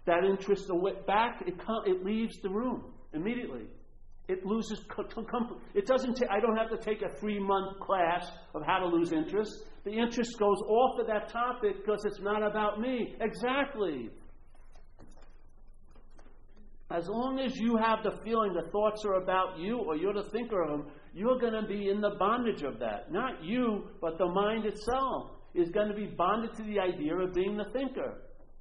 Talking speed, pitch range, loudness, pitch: 185 wpm, 195-230 Hz, -32 LUFS, 210 Hz